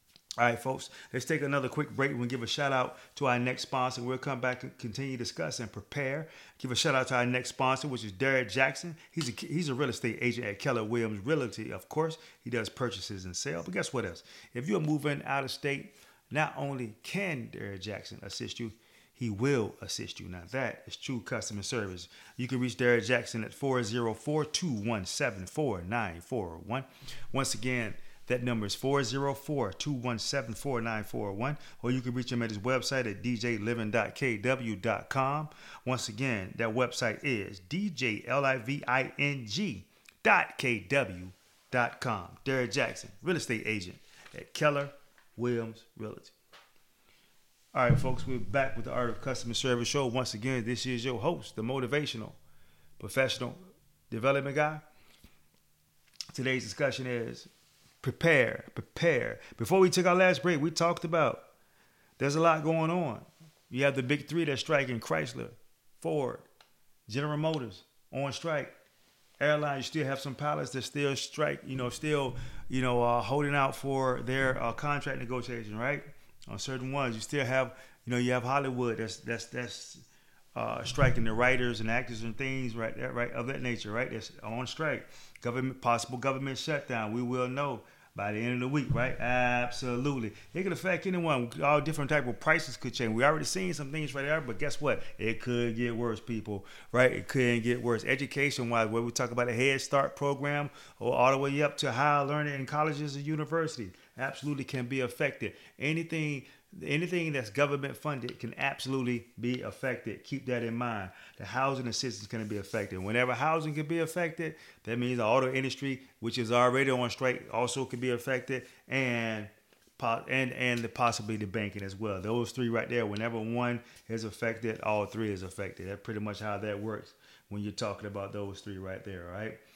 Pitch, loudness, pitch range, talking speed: 125 Hz, -32 LUFS, 115-140 Hz, 175 wpm